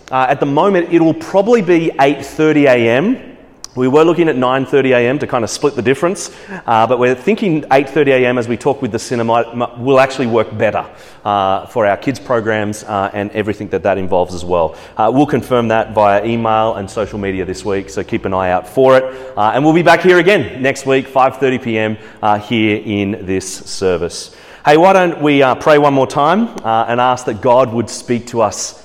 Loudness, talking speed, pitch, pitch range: -13 LUFS, 220 wpm, 125 Hz, 110-145 Hz